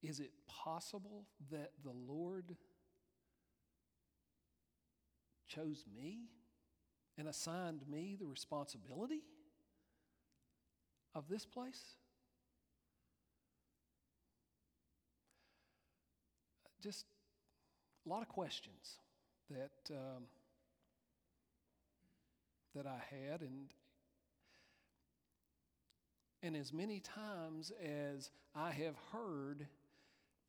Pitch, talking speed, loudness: 140 Hz, 70 wpm, -50 LUFS